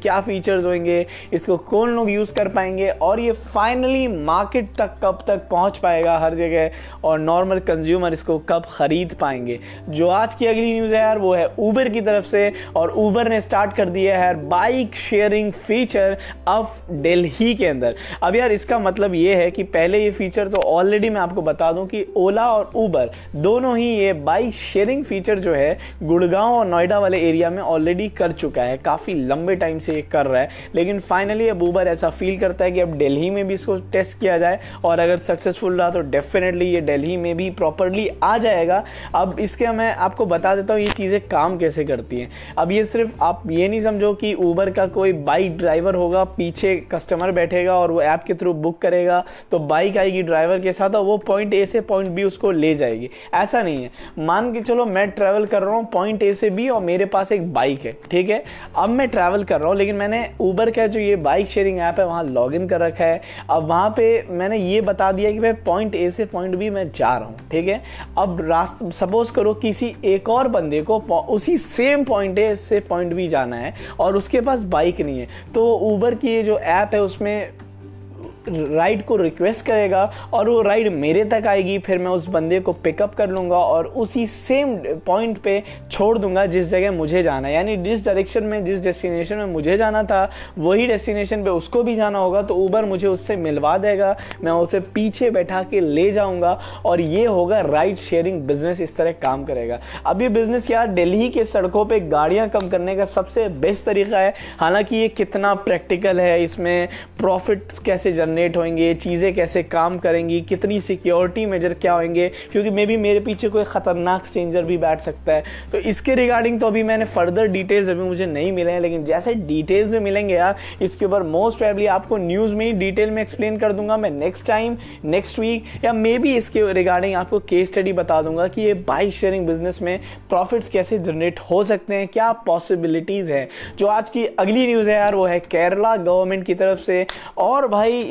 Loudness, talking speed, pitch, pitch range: -19 LUFS, 205 wpm, 195 Hz, 175-215 Hz